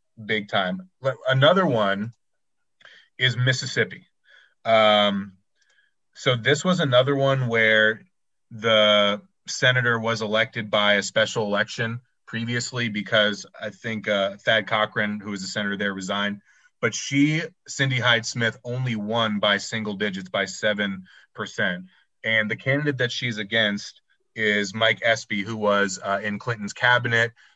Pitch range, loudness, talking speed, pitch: 105-125 Hz, -22 LUFS, 135 wpm, 110 Hz